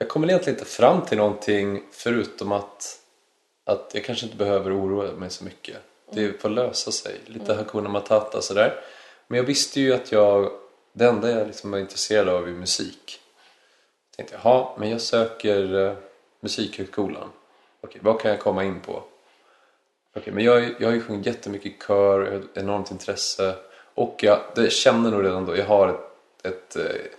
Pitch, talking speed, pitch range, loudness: 105 Hz, 180 wpm, 100-115 Hz, -23 LUFS